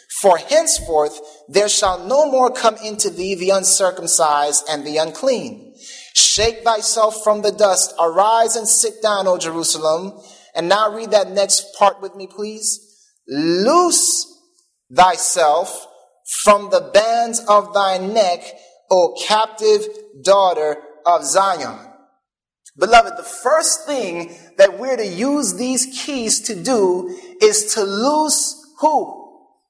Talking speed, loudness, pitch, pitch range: 125 wpm, -16 LUFS, 215 Hz, 190-285 Hz